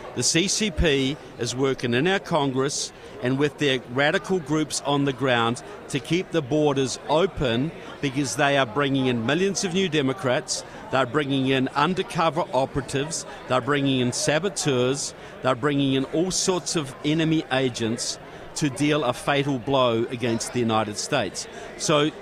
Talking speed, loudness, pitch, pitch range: 150 wpm, -24 LUFS, 140 Hz, 130-155 Hz